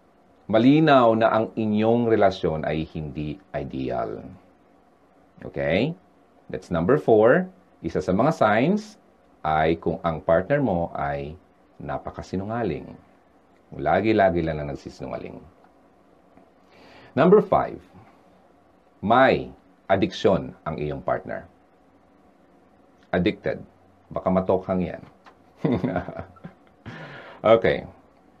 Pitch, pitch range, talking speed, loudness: 90 Hz, 75-110 Hz, 80 wpm, -23 LUFS